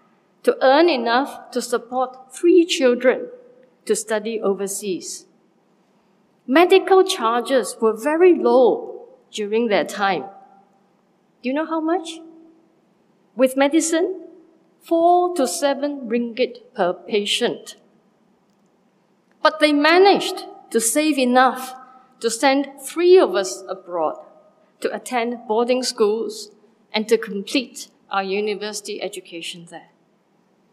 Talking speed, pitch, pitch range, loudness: 105 wpm, 235 Hz, 200-310 Hz, -19 LUFS